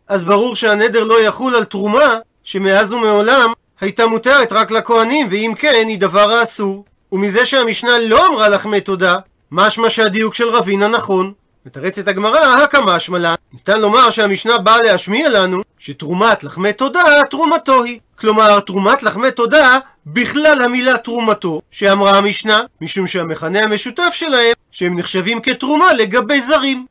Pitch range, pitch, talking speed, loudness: 195-245 Hz, 220 Hz, 140 wpm, -12 LUFS